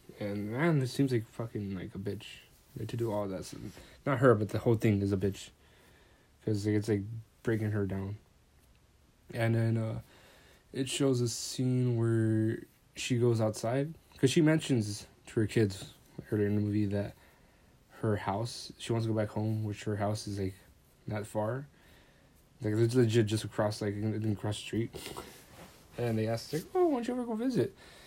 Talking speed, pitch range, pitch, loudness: 185 wpm, 105-120 Hz, 110 Hz, -32 LUFS